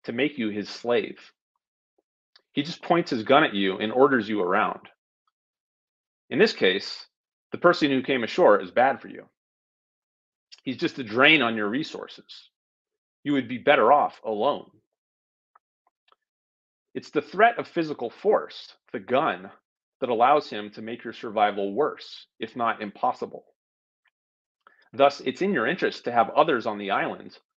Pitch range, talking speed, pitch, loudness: 110-150 Hz, 155 wpm, 135 Hz, -24 LUFS